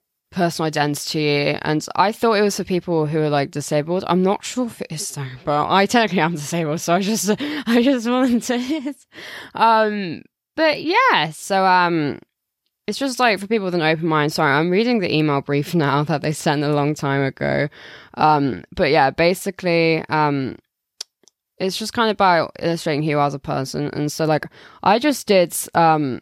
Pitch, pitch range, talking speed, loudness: 170 Hz, 150-210 Hz, 190 wpm, -19 LUFS